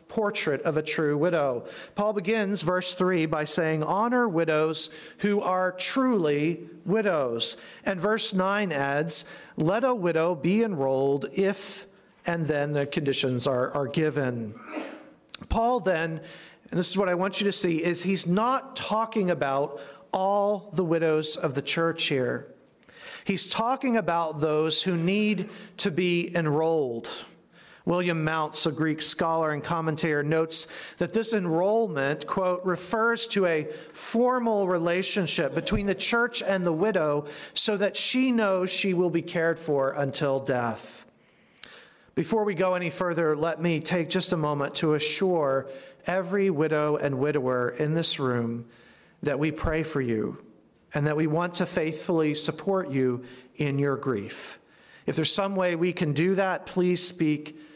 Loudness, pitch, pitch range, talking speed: -26 LUFS, 170 Hz, 150-195 Hz, 150 wpm